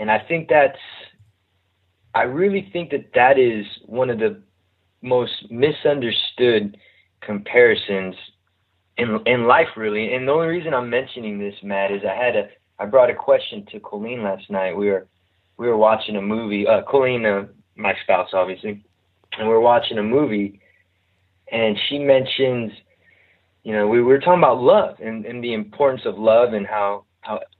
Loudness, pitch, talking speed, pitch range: -19 LUFS, 105 Hz, 165 wpm, 95-120 Hz